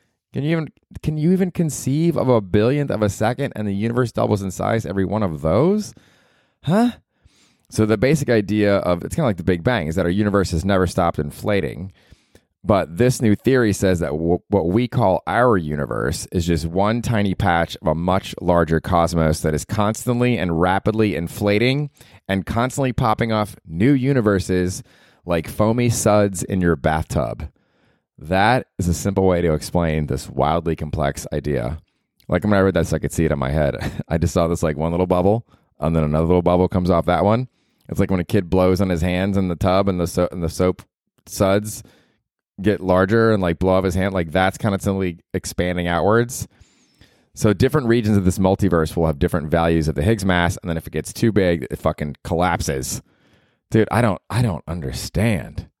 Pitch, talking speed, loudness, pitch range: 95 Hz, 205 wpm, -20 LUFS, 85-110 Hz